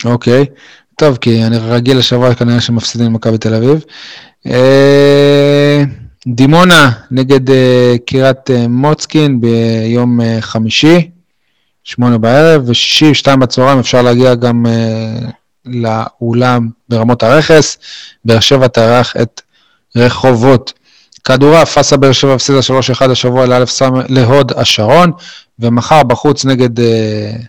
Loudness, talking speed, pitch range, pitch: -9 LUFS, 105 wpm, 120-140 Hz, 125 Hz